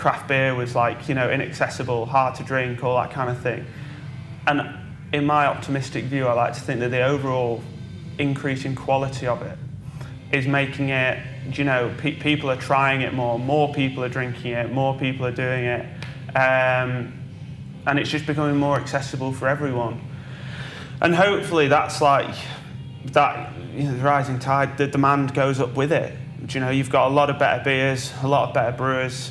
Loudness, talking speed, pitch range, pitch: -22 LUFS, 190 wpm, 130-140 Hz, 135 Hz